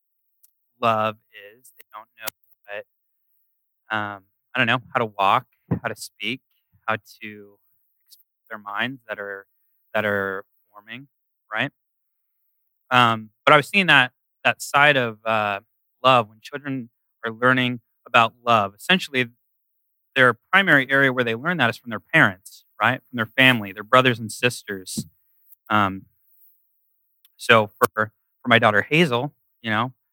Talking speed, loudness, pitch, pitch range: 145 wpm, -20 LUFS, 115 Hz, 105-130 Hz